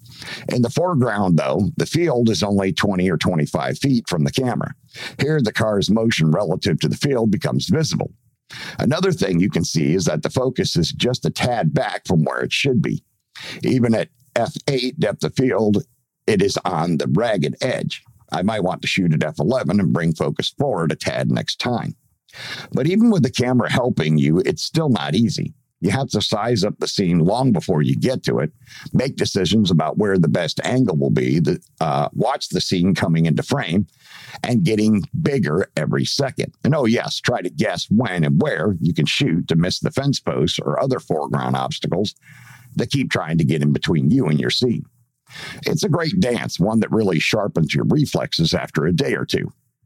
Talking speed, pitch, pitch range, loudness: 195 wpm, 110 Hz, 80-125 Hz, -19 LUFS